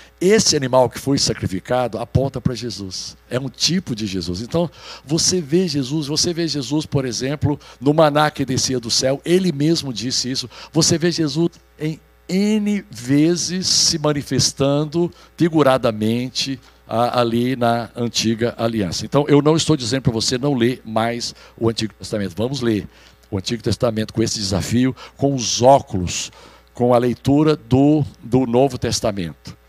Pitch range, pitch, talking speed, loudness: 115-150 Hz, 130 Hz, 155 wpm, -19 LUFS